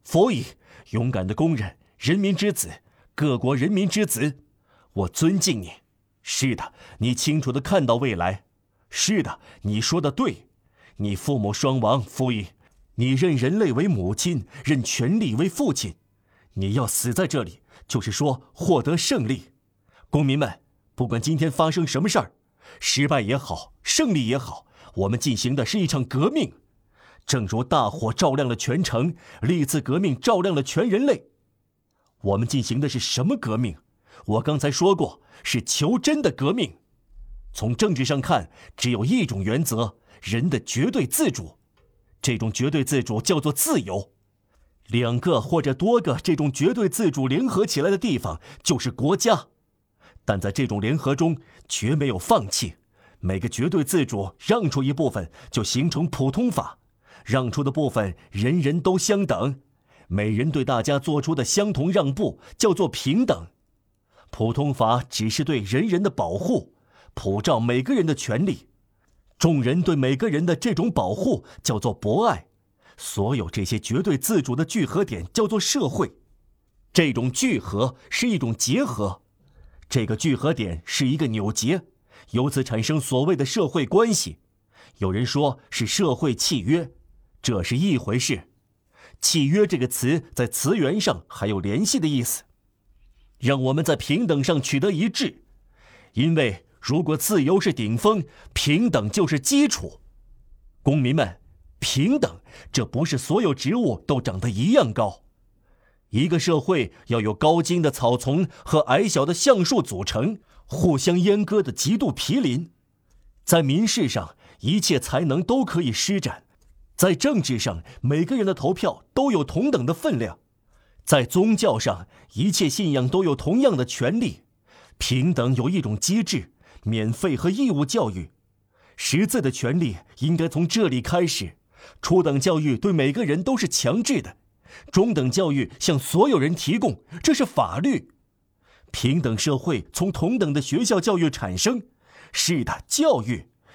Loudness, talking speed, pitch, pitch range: -23 LUFS, 225 characters per minute, 135 Hz, 110-165 Hz